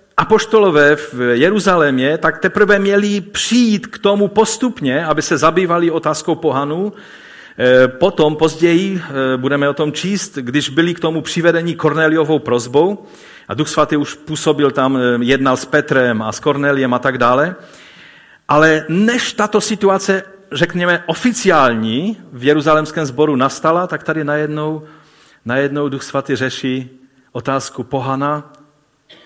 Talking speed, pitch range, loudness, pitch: 125 wpm, 135-180 Hz, -15 LUFS, 155 Hz